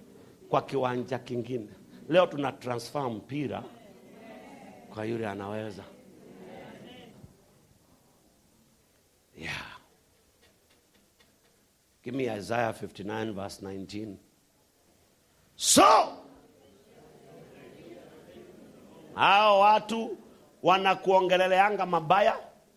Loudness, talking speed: -27 LUFS, 45 wpm